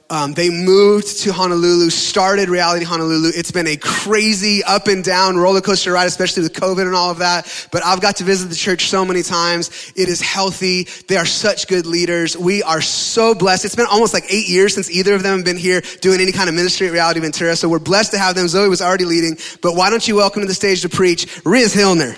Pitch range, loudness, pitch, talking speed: 175-195 Hz, -14 LUFS, 185 Hz, 245 wpm